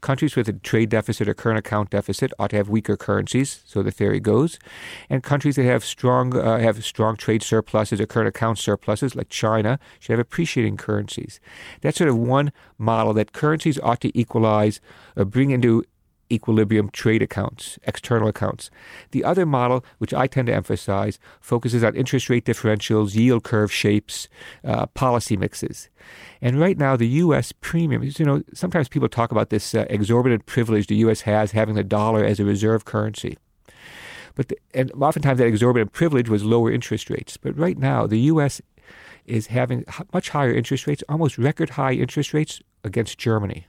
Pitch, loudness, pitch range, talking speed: 115 Hz, -21 LUFS, 110-135 Hz, 175 wpm